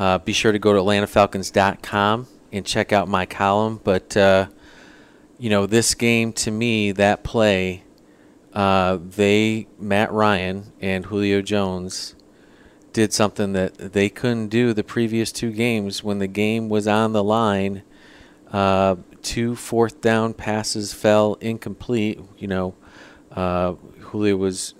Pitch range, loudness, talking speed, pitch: 95-110 Hz, -20 LUFS, 140 wpm, 105 Hz